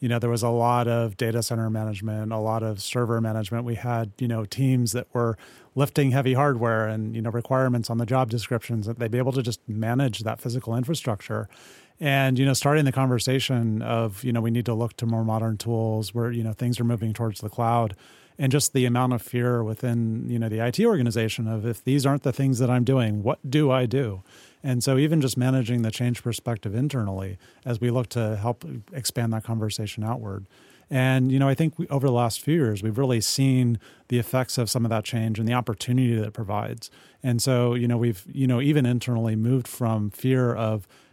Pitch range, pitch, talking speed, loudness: 110-130 Hz, 120 Hz, 220 wpm, -25 LUFS